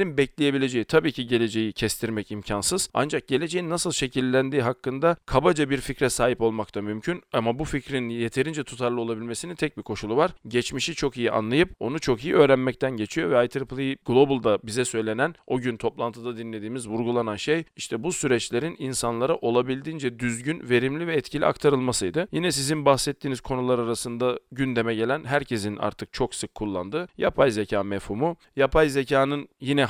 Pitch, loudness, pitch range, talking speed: 130 Hz, -25 LUFS, 115-145 Hz, 150 wpm